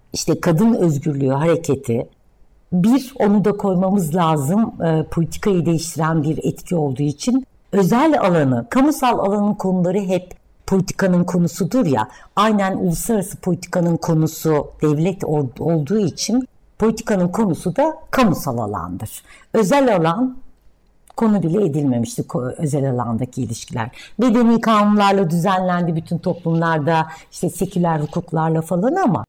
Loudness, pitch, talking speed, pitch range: -18 LUFS, 175 Hz, 115 wpm, 155-205 Hz